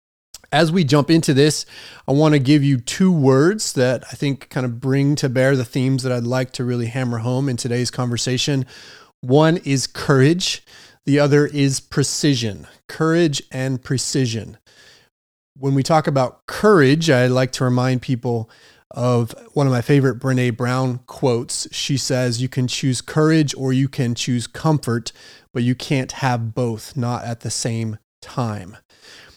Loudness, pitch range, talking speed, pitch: -19 LUFS, 125-145 Hz, 165 wpm, 130 Hz